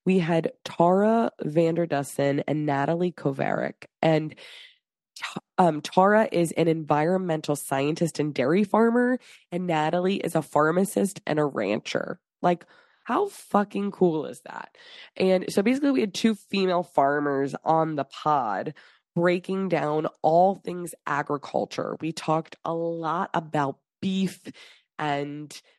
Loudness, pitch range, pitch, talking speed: -25 LUFS, 150-190 Hz, 170 Hz, 125 wpm